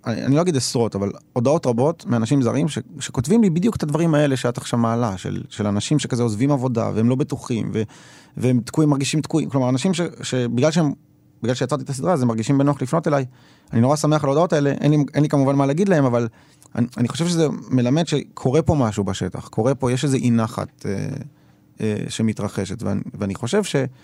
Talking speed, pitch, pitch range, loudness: 215 wpm, 135 Hz, 120-150 Hz, -21 LUFS